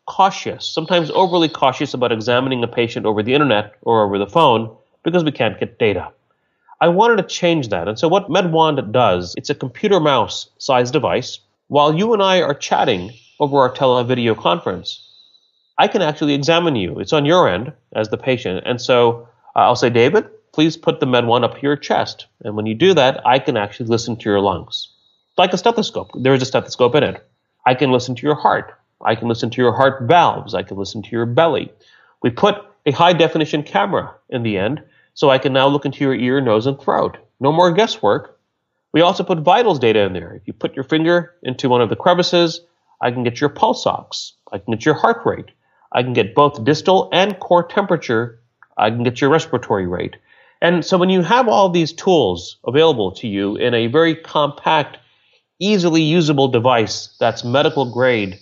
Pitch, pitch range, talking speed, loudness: 140 Hz, 120-170 Hz, 205 wpm, -16 LUFS